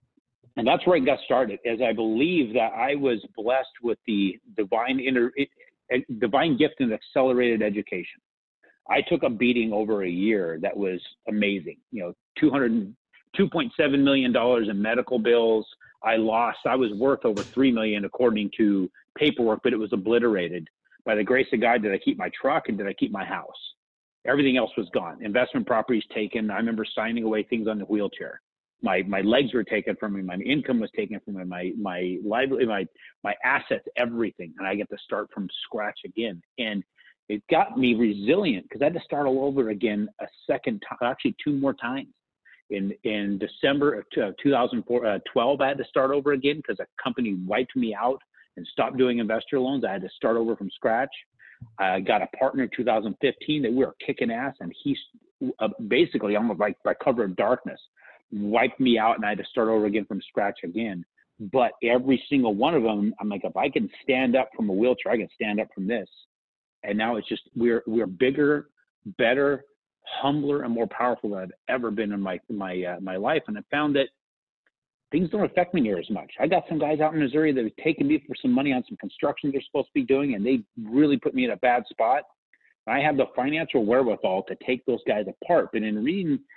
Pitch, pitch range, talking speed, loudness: 120 Hz, 105-145 Hz, 210 wpm, -25 LUFS